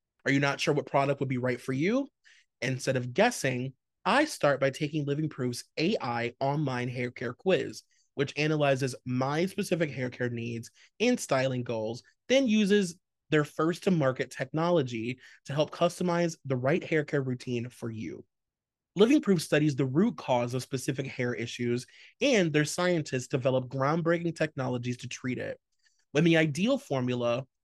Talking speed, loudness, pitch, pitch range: 165 wpm, -29 LUFS, 140 Hz, 125-165 Hz